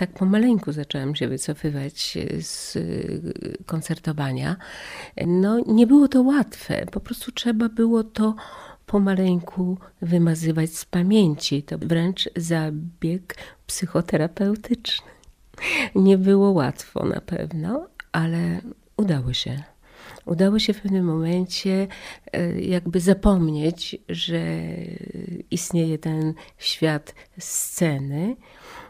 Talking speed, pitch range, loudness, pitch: 95 wpm, 160-205 Hz, -23 LUFS, 180 Hz